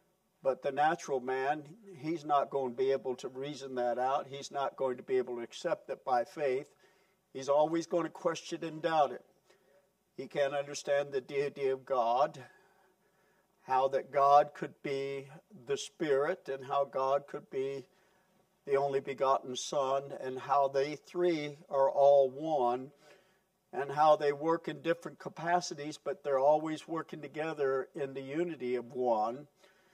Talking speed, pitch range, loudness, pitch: 160 wpm, 135-185 Hz, -33 LUFS, 150 Hz